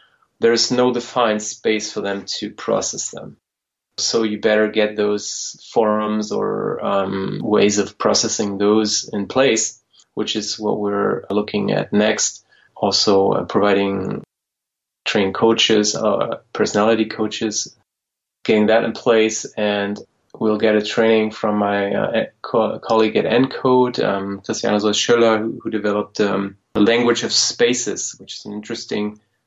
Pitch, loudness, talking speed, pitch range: 105 Hz, -18 LUFS, 145 wpm, 105-110 Hz